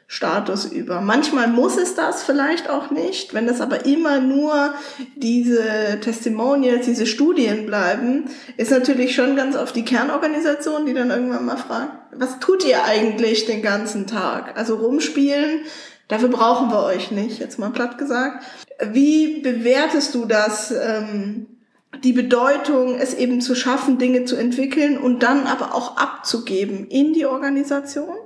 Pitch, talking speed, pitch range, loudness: 255 Hz, 150 wpm, 230-280 Hz, -19 LUFS